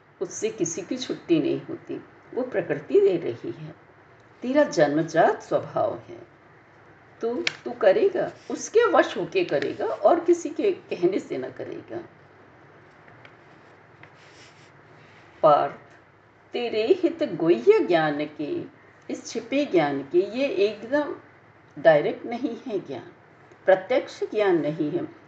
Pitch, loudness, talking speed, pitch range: 330 Hz, -24 LUFS, 90 wpm, 280-365 Hz